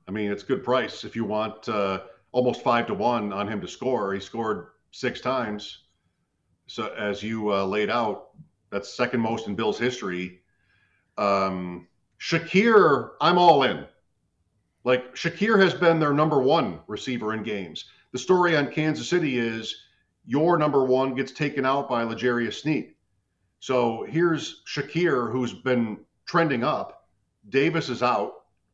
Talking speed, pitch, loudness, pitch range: 150 wpm, 120 Hz, -24 LUFS, 100-140 Hz